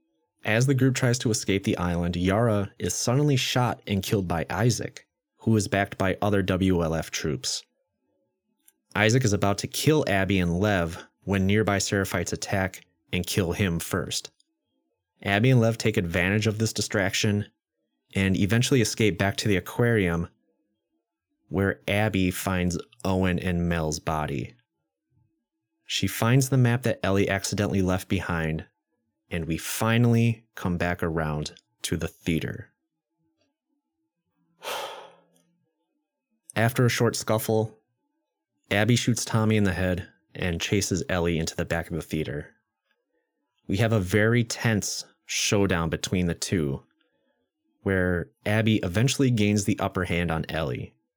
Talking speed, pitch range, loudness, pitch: 135 wpm, 90-115 Hz, -25 LUFS, 100 Hz